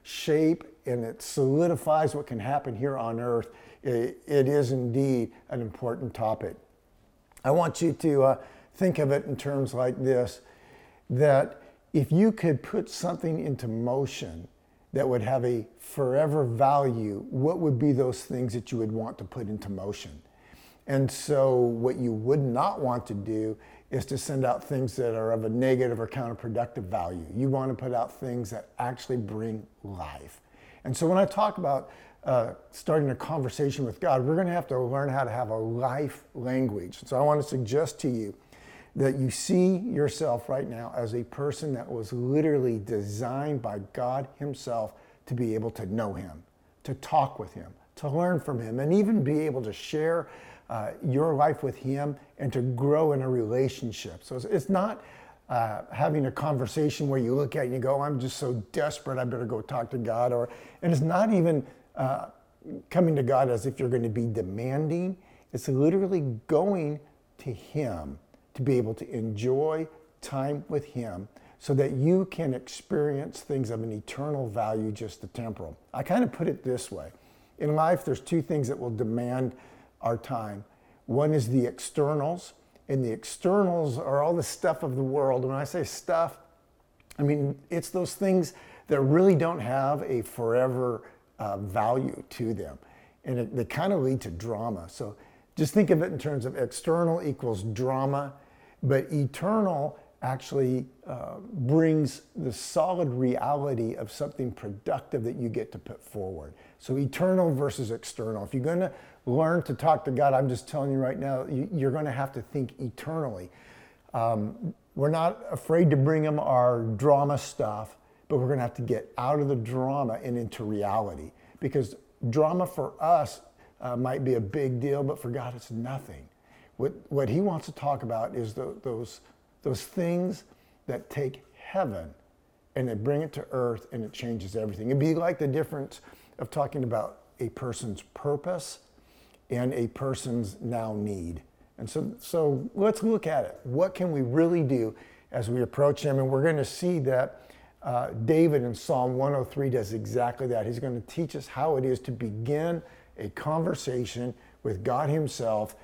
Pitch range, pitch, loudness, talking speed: 120-150 Hz, 130 Hz, -28 LUFS, 180 wpm